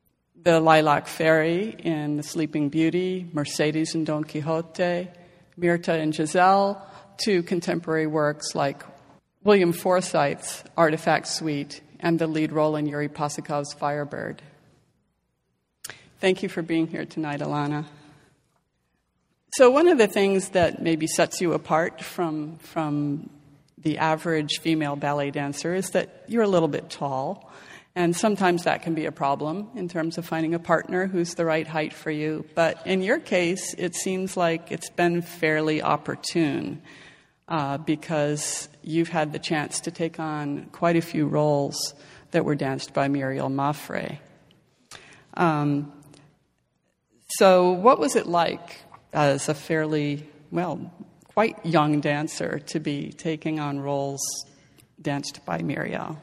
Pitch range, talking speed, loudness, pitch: 150-175 Hz, 140 wpm, -24 LUFS, 160 Hz